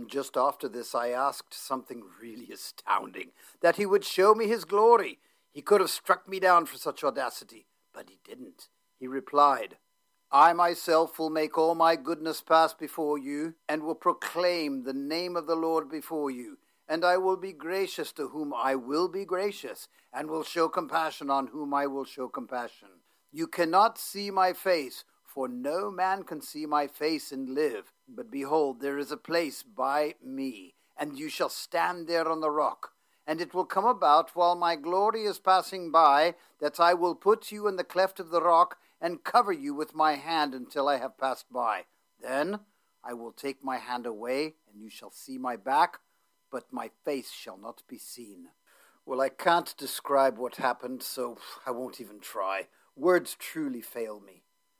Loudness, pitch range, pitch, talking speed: -28 LUFS, 140-185 Hz, 160 Hz, 185 wpm